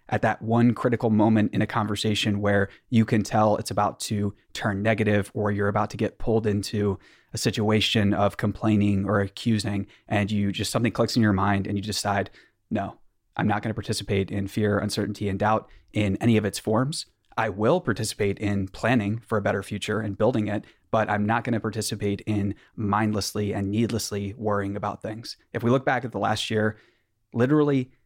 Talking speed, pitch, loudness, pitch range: 195 wpm, 105 Hz, -25 LUFS, 100-110 Hz